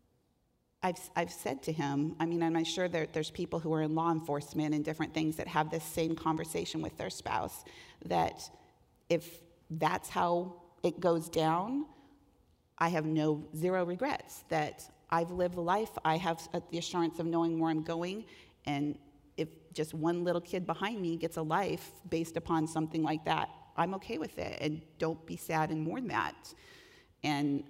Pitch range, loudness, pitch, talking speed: 155-175 Hz, -34 LUFS, 165 Hz, 180 wpm